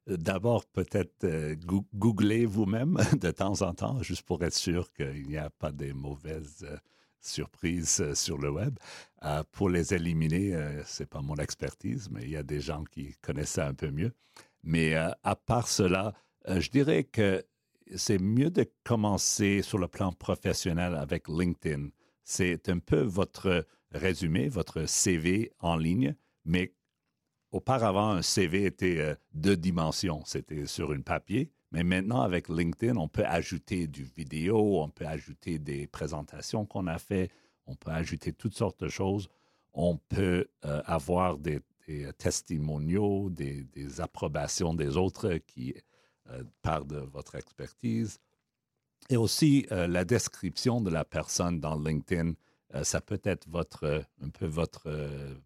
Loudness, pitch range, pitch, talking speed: -31 LUFS, 75-95 Hz, 85 Hz, 160 wpm